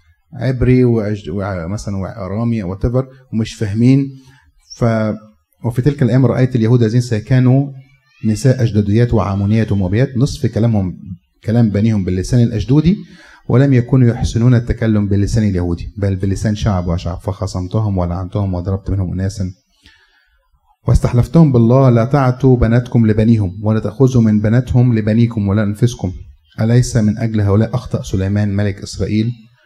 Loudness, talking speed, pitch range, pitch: -15 LUFS, 125 wpm, 100-125 Hz, 110 Hz